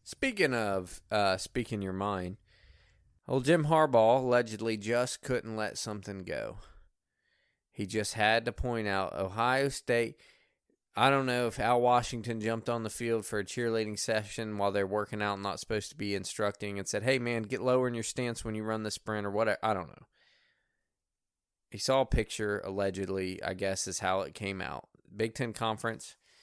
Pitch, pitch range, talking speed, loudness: 110 Hz, 100-120 Hz, 185 wpm, -31 LUFS